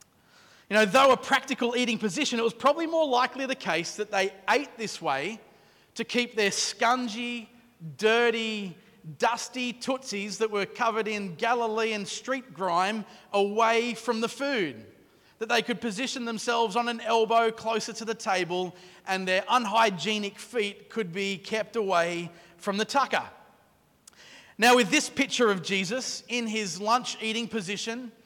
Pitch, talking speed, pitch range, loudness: 225 Hz, 150 wpm, 205-240 Hz, -27 LUFS